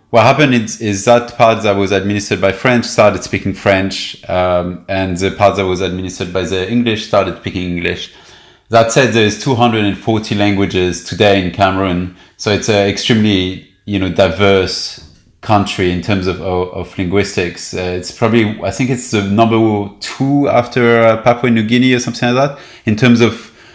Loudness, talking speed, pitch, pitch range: -13 LUFS, 175 wpm, 100 Hz, 95-115 Hz